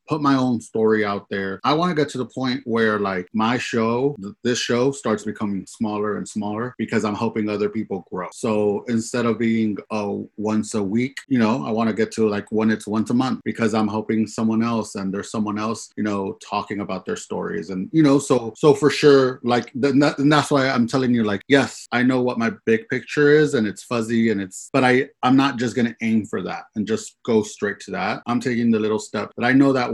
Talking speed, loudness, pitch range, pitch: 245 wpm, -21 LUFS, 105-130 Hz, 115 Hz